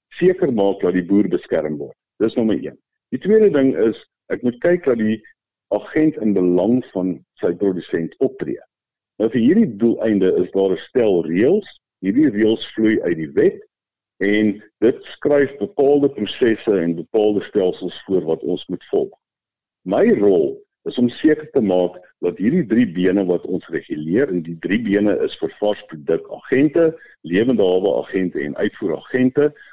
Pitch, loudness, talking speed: 125 Hz, -19 LUFS, 160 wpm